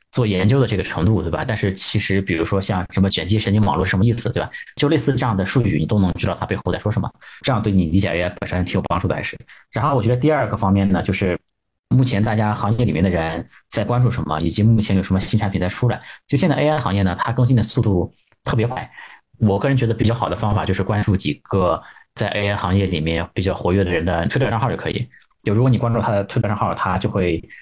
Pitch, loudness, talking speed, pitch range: 100 Hz, -19 LUFS, 390 characters per minute, 95-115 Hz